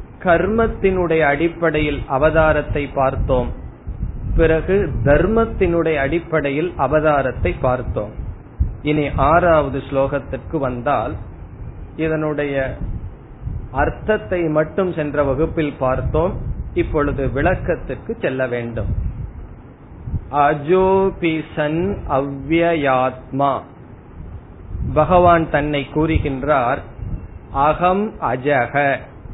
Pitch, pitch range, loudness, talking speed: 145 Hz, 130-160 Hz, -18 LUFS, 60 wpm